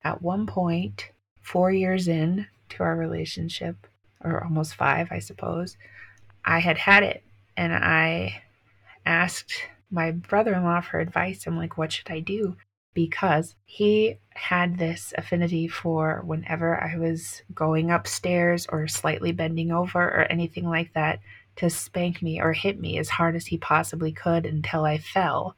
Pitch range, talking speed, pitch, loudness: 155-175 Hz, 155 wpm, 165 Hz, -25 LUFS